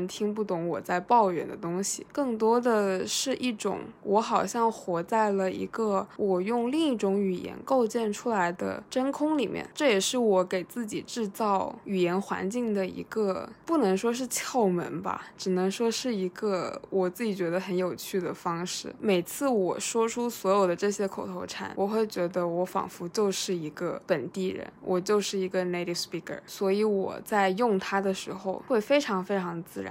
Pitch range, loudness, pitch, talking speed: 185-230 Hz, -28 LUFS, 195 Hz, 285 characters per minute